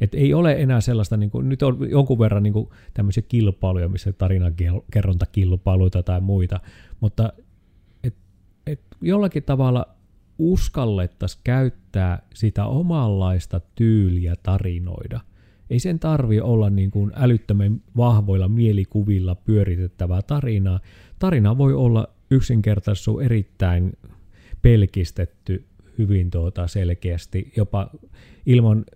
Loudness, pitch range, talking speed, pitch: -21 LUFS, 95-120 Hz, 110 wpm, 100 Hz